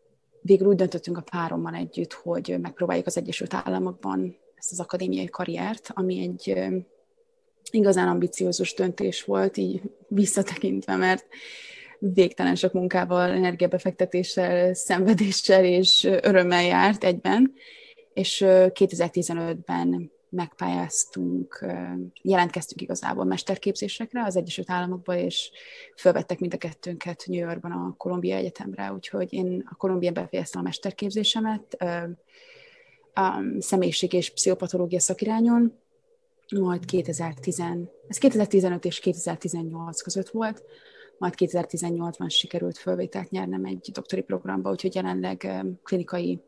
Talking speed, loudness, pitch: 105 wpm, -25 LUFS, 180 Hz